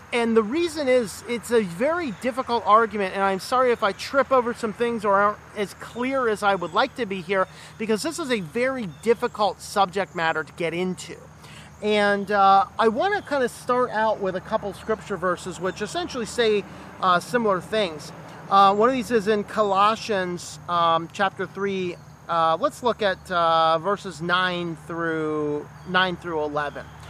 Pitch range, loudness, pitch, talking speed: 175-235 Hz, -23 LUFS, 200 Hz, 180 wpm